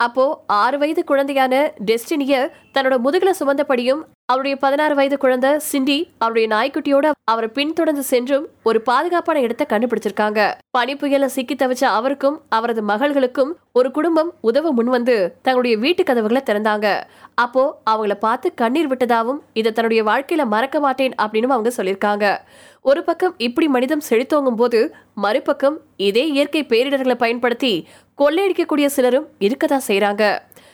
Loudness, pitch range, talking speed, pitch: -18 LUFS, 230-290 Hz, 130 wpm, 265 Hz